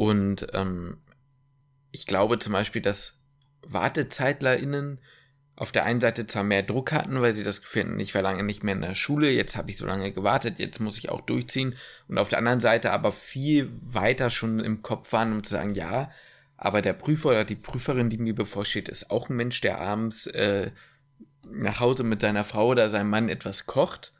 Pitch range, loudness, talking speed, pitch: 105-135 Hz, -26 LUFS, 200 wpm, 115 Hz